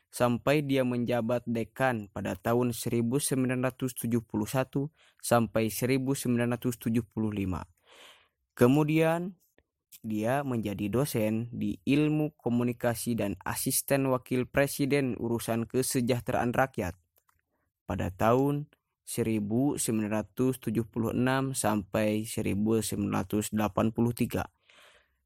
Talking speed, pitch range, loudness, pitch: 65 wpm, 110-130 Hz, -29 LUFS, 120 Hz